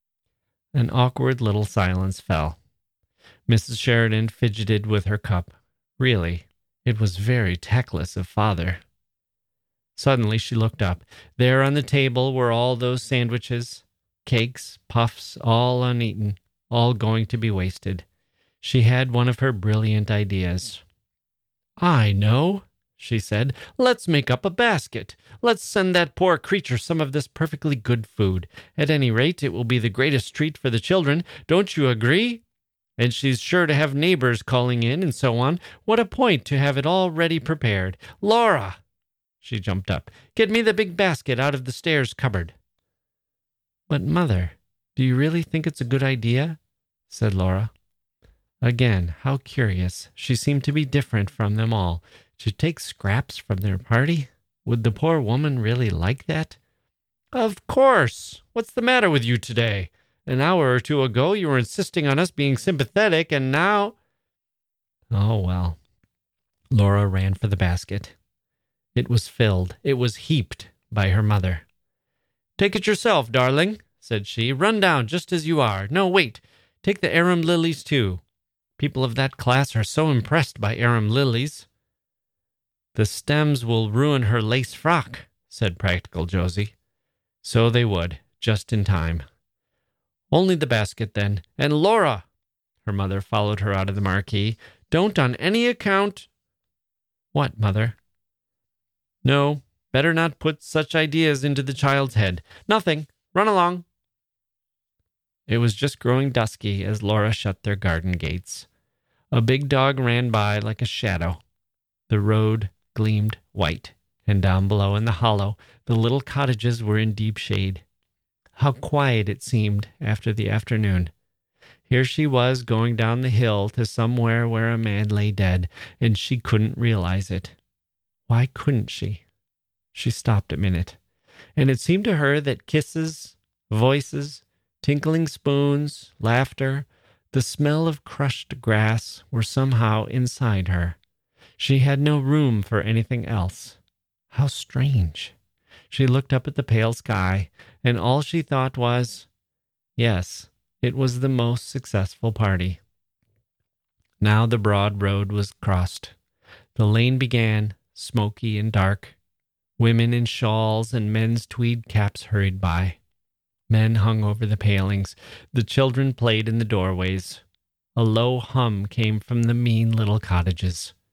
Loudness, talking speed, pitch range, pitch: -22 LUFS, 150 wpm, 100-135 Hz, 115 Hz